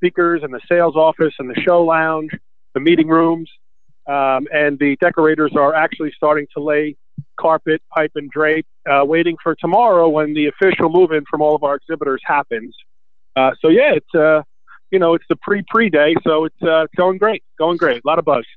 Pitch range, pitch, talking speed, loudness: 150-165 Hz, 155 Hz, 200 wpm, -16 LUFS